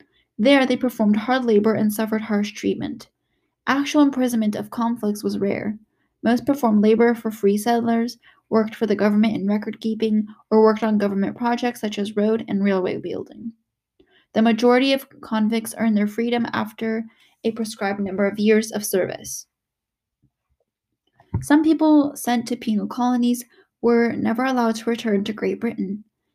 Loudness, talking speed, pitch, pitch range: -21 LUFS, 155 wpm, 225 Hz, 215-240 Hz